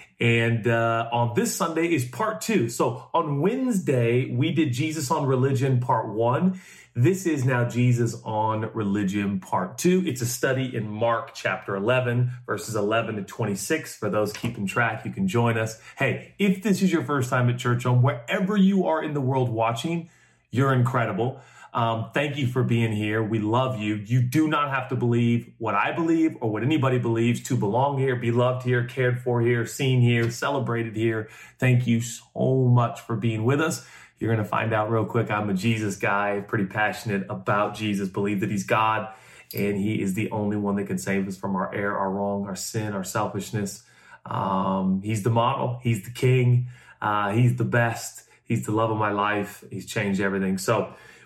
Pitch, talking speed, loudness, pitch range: 115 Hz, 195 wpm, -24 LUFS, 105-130 Hz